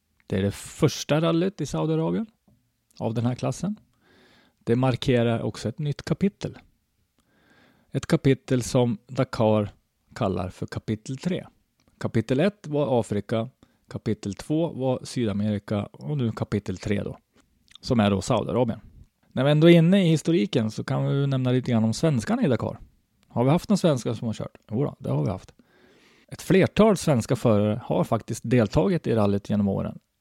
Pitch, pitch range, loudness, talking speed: 125 Hz, 110-150 Hz, -25 LUFS, 165 wpm